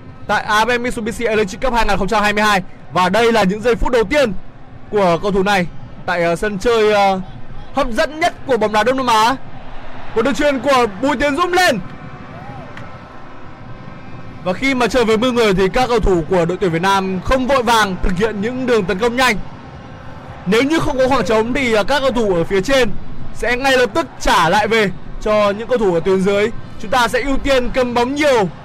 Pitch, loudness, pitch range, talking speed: 215 Hz, -16 LUFS, 180-250 Hz, 205 wpm